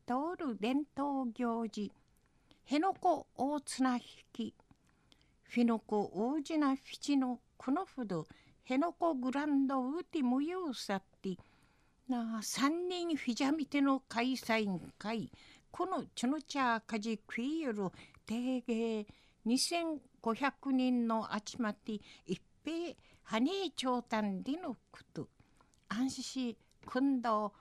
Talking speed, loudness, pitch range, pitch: 200 characters per minute, -36 LUFS, 225-280 Hz, 255 Hz